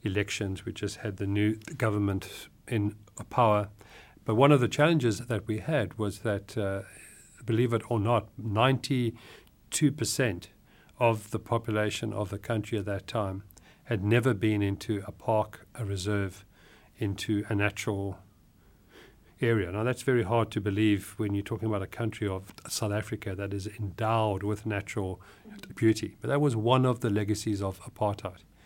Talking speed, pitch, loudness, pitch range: 160 wpm, 105 Hz, -29 LUFS, 100-115 Hz